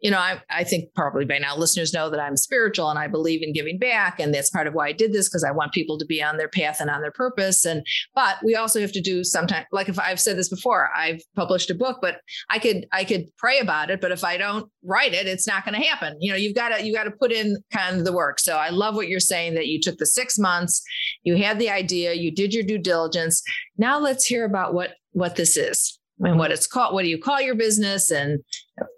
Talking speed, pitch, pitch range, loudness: 270 wpm, 185 Hz, 165-215 Hz, -22 LUFS